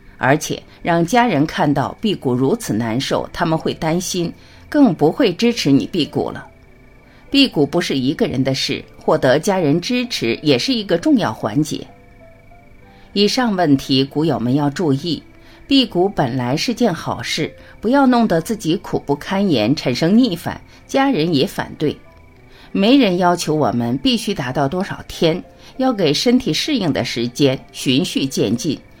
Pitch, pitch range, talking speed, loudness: 160 Hz, 135-225 Hz, 235 characters per minute, -17 LUFS